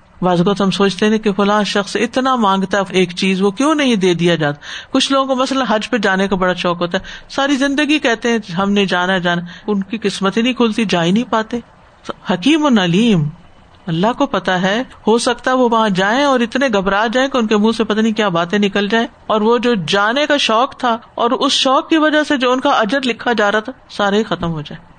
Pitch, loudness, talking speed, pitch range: 220 Hz, -15 LUFS, 245 wpm, 195-255 Hz